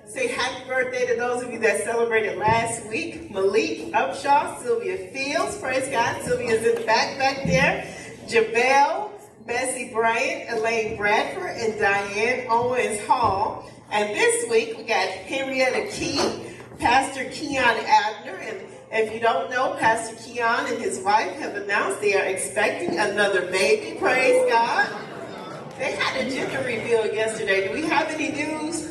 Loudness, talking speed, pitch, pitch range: -23 LUFS, 150 wpm, 245 Hz, 220-300 Hz